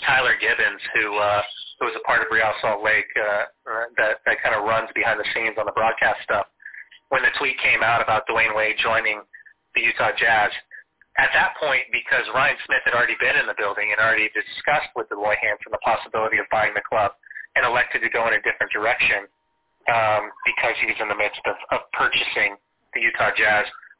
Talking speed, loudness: 205 wpm, -20 LUFS